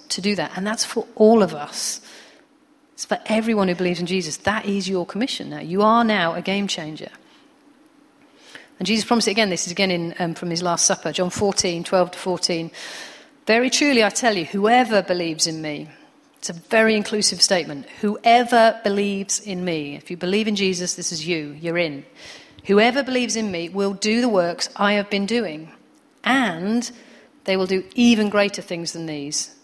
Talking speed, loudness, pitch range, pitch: 190 wpm, -20 LUFS, 180-240 Hz, 205 Hz